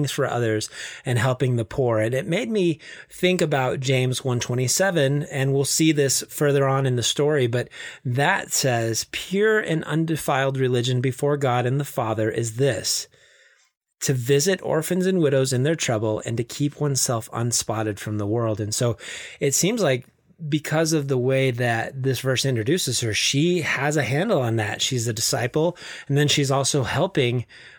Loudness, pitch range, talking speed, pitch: -22 LUFS, 120-150 Hz, 175 wpm, 135 Hz